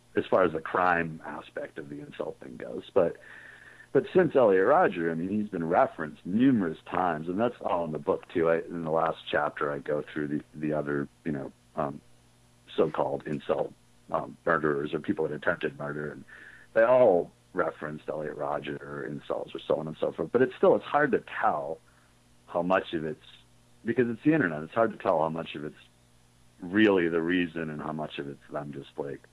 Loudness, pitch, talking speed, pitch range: -28 LUFS, 75 Hz, 210 wpm, 60-80 Hz